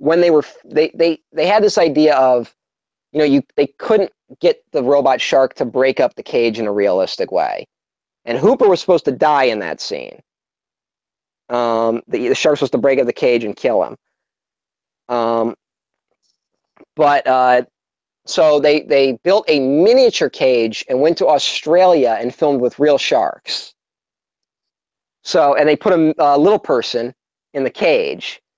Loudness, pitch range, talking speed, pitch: -15 LUFS, 125-180 Hz, 170 wpm, 145 Hz